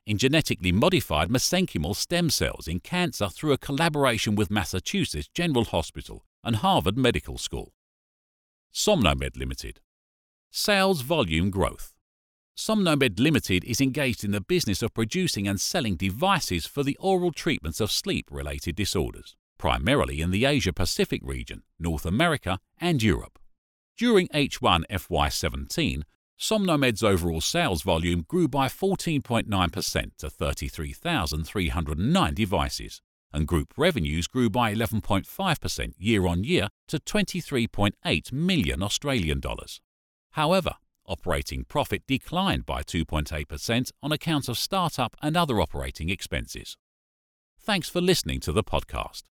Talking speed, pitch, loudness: 125 wpm, 100 Hz, -26 LUFS